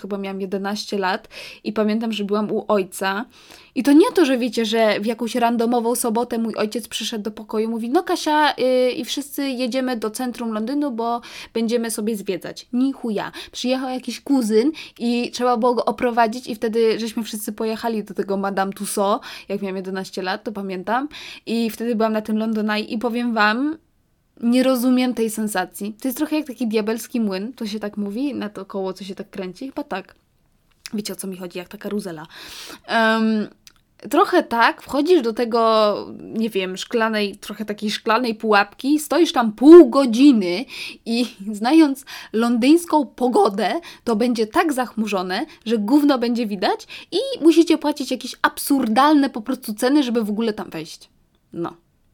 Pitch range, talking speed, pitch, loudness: 210-260 Hz, 170 wpm, 230 Hz, -20 LUFS